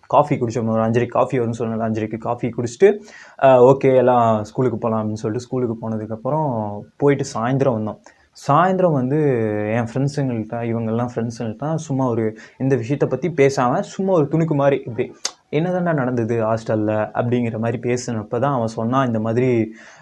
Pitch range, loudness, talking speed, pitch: 115-135 Hz, -19 LUFS, 145 wpm, 120 Hz